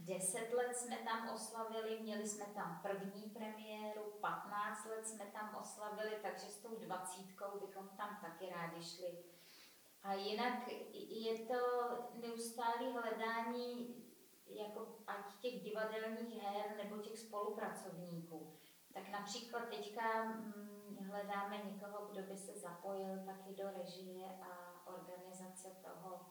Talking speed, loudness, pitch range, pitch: 120 wpm, -46 LUFS, 190-225 Hz, 205 Hz